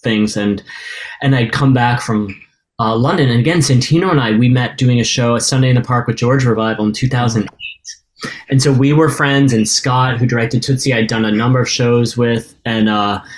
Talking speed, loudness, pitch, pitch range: 215 wpm, -14 LUFS, 120 Hz, 115-135 Hz